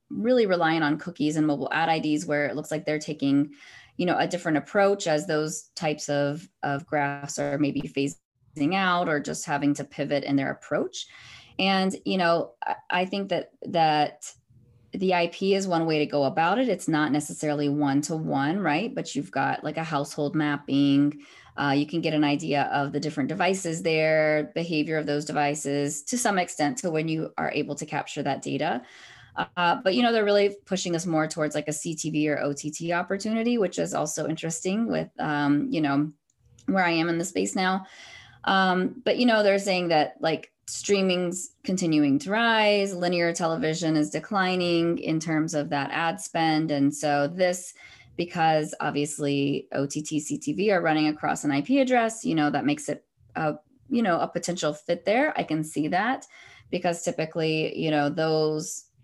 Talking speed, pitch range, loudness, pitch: 185 wpm, 145-180 Hz, -26 LUFS, 155 Hz